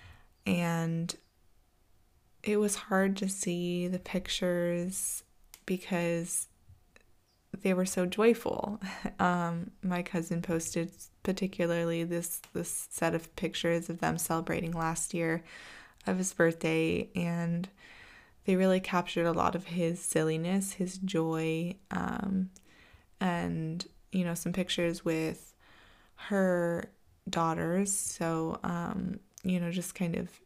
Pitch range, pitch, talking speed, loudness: 165-185 Hz, 175 Hz, 115 wpm, -32 LUFS